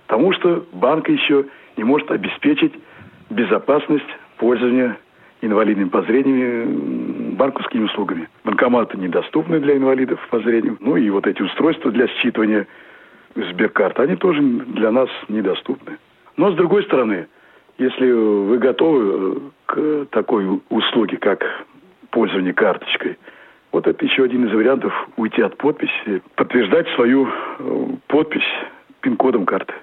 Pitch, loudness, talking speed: 140 Hz, -18 LUFS, 120 wpm